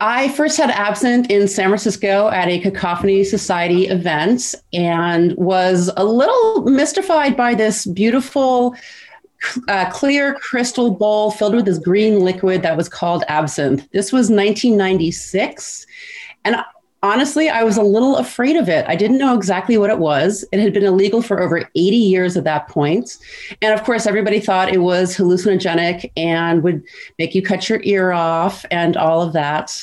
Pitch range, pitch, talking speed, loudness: 180-240 Hz, 200 Hz, 165 wpm, -16 LUFS